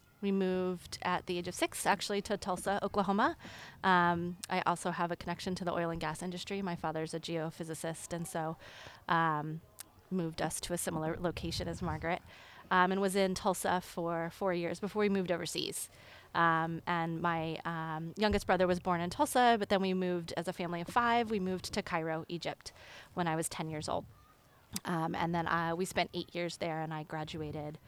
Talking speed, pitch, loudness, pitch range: 200 wpm, 175 Hz, -34 LUFS, 165-185 Hz